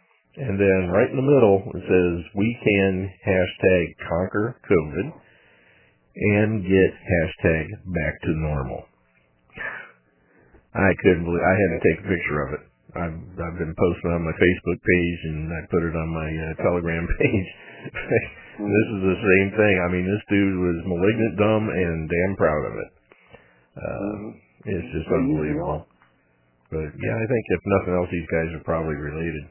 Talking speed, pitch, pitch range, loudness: 165 wpm, 90 Hz, 80-100 Hz, -23 LUFS